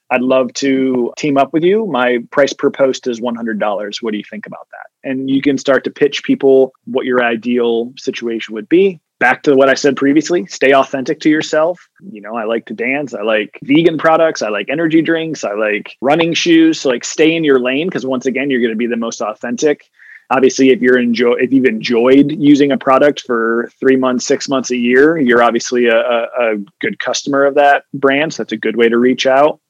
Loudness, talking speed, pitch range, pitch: -13 LUFS, 225 wpm, 120-145 Hz, 130 Hz